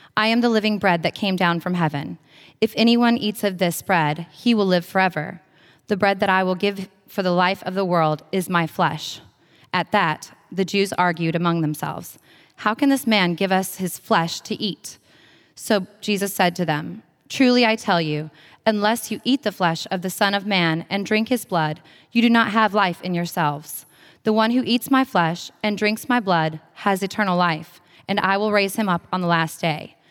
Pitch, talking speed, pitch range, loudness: 190 Hz, 210 wpm, 170-210 Hz, -21 LUFS